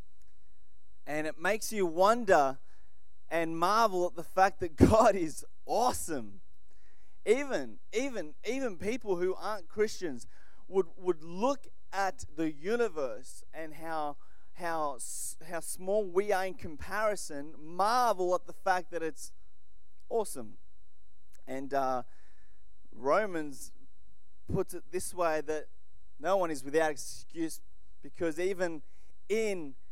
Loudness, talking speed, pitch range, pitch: -32 LUFS, 120 wpm, 130-190 Hz, 165 Hz